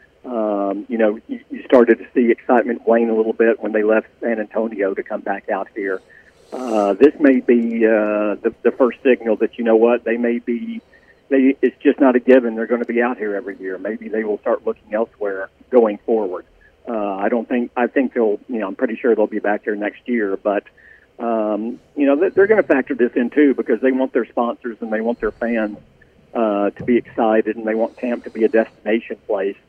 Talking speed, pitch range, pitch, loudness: 230 wpm, 105-125 Hz, 115 Hz, -18 LUFS